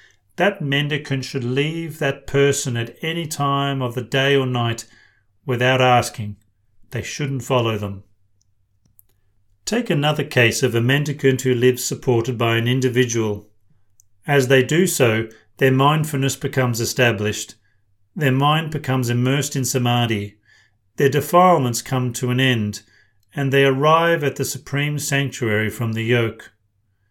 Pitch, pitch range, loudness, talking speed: 125 Hz, 110-140 Hz, -19 LUFS, 135 wpm